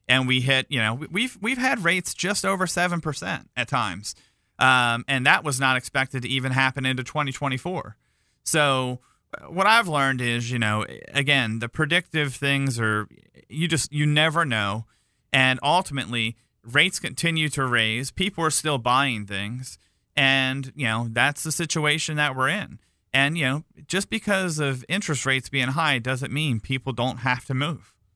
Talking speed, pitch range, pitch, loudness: 170 wpm, 125-155 Hz, 135 Hz, -23 LUFS